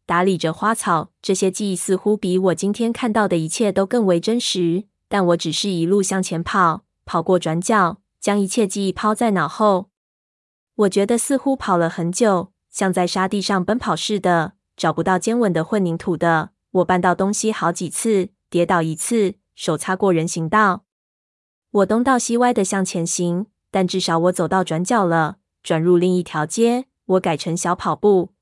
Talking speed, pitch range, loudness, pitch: 260 characters per minute, 170-205 Hz, -19 LUFS, 185 Hz